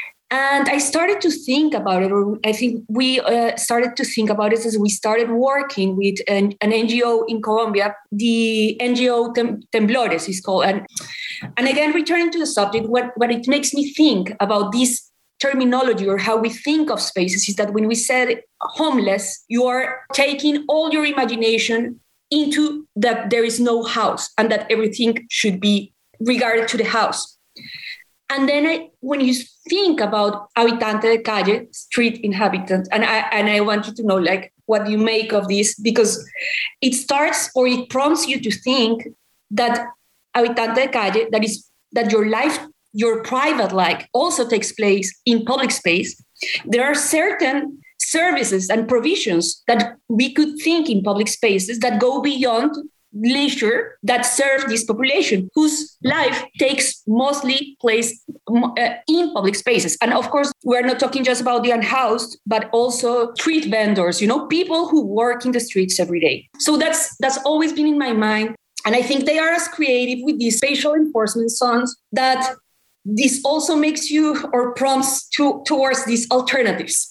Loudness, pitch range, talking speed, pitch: -18 LUFS, 220-275 Hz, 170 wpm, 240 Hz